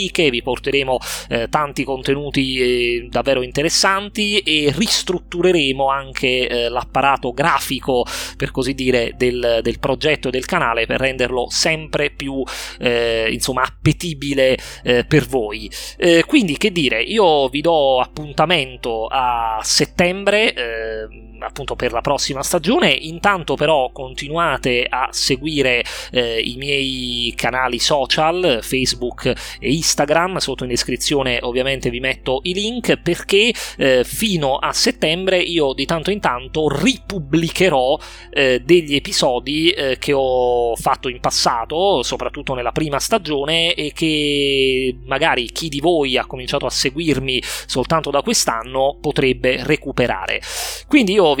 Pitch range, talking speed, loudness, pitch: 125-160 Hz, 130 wpm, -17 LUFS, 135 Hz